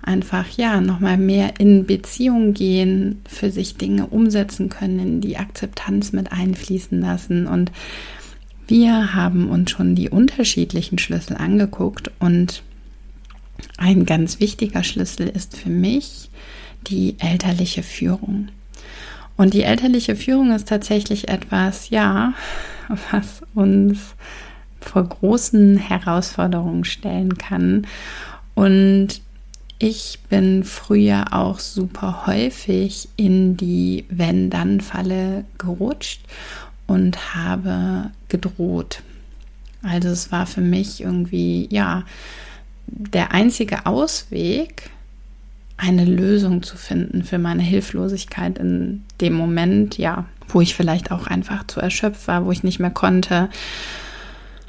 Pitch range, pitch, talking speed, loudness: 175-205 Hz, 190 Hz, 110 wpm, -19 LUFS